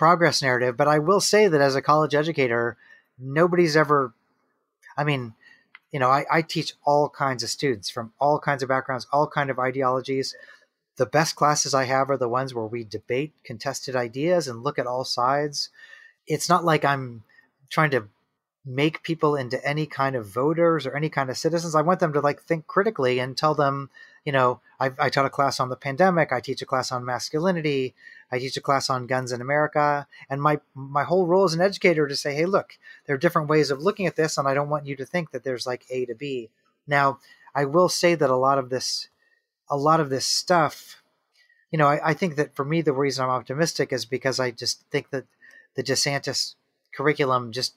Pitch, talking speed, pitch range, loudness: 140 Hz, 215 wpm, 130-155 Hz, -23 LUFS